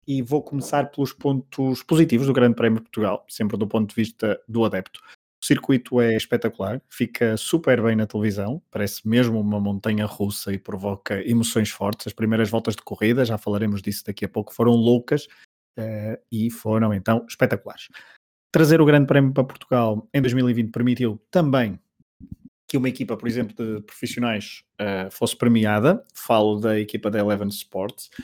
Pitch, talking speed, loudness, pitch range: 115 Hz, 170 wpm, -22 LUFS, 105-130 Hz